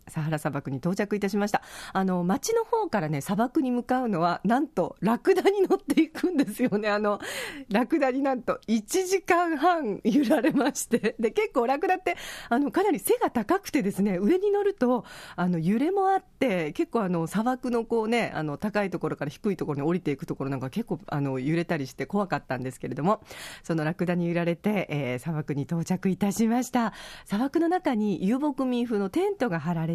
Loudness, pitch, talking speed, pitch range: -27 LUFS, 215 Hz, 395 characters per minute, 175-285 Hz